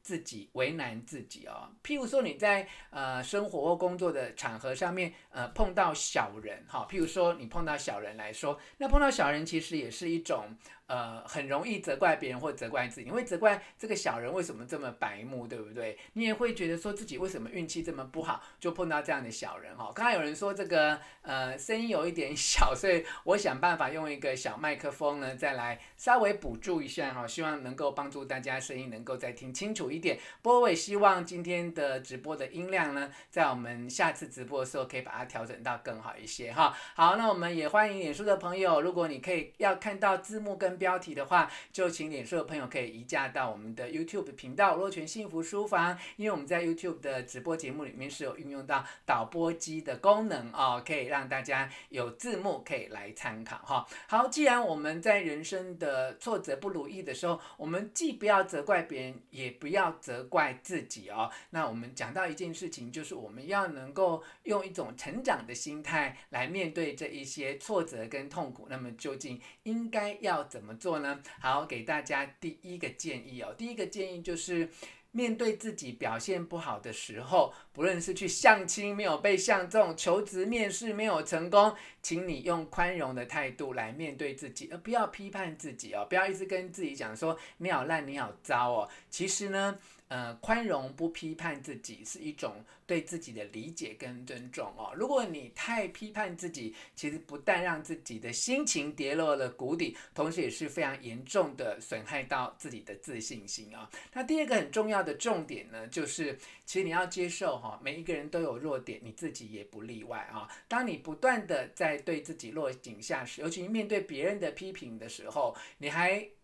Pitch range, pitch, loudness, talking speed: 140-195 Hz, 170 Hz, -33 LUFS, 310 characters per minute